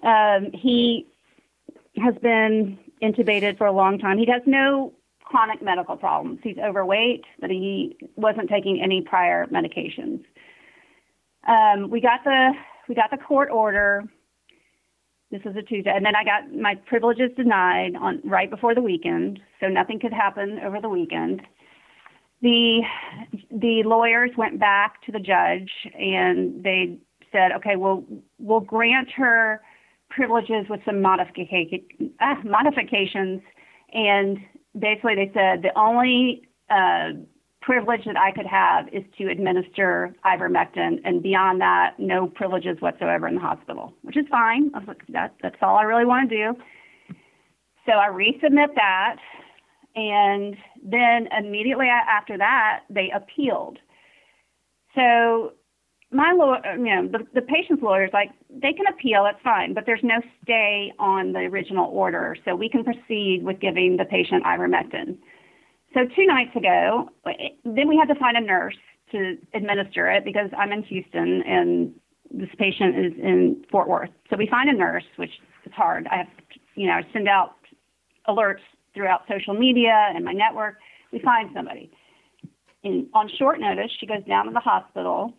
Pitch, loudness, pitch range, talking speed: 215 Hz, -21 LUFS, 195-245 Hz, 155 wpm